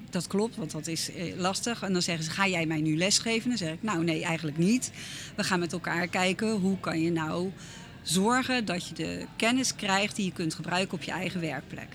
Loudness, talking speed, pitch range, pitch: -29 LUFS, 225 wpm, 160-195 Hz, 180 Hz